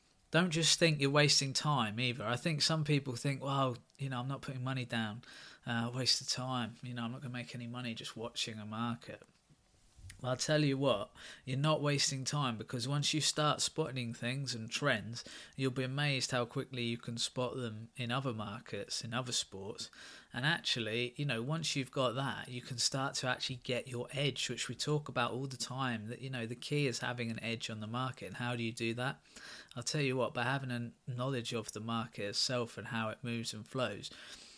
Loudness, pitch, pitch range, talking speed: -36 LUFS, 125 Hz, 115-135 Hz, 220 wpm